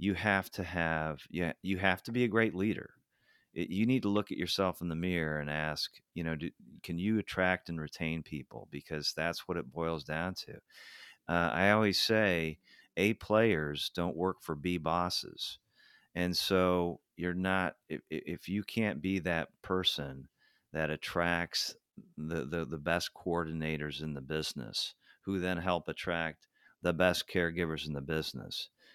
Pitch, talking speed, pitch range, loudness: 85 Hz, 165 wpm, 80-95 Hz, -34 LUFS